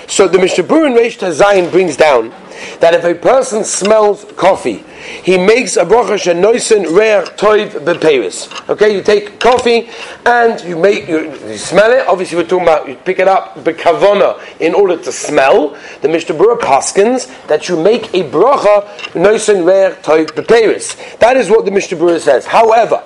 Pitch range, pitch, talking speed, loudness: 180-235 Hz, 205 Hz, 170 wpm, -11 LUFS